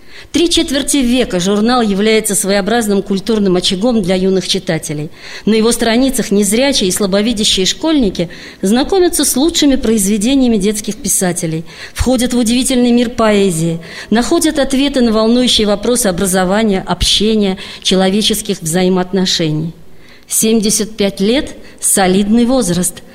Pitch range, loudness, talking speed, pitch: 190-245 Hz, -12 LUFS, 110 wpm, 215 Hz